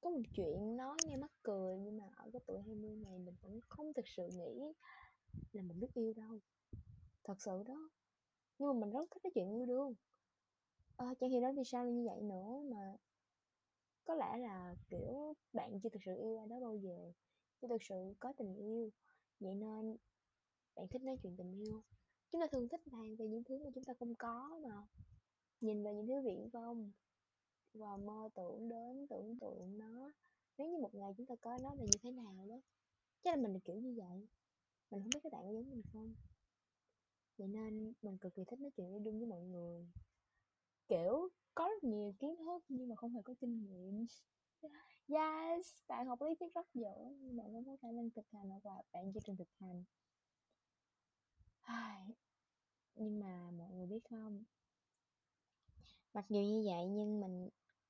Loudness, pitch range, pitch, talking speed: -46 LUFS, 200-255 Hz, 225 Hz, 195 wpm